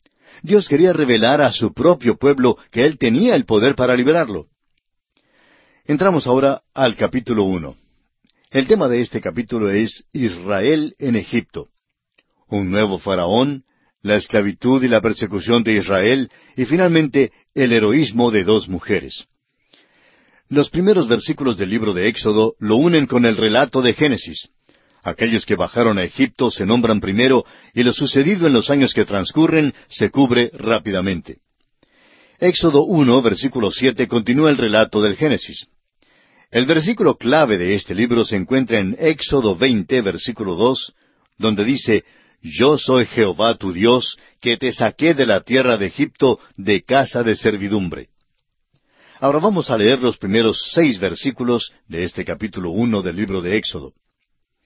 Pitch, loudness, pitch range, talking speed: 120 Hz, -17 LUFS, 105-135 Hz, 150 wpm